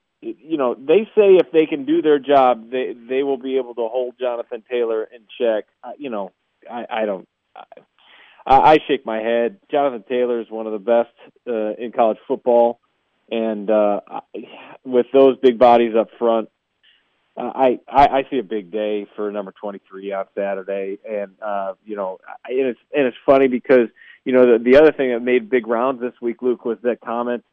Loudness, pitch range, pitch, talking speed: -18 LUFS, 110-130 Hz, 120 Hz, 200 wpm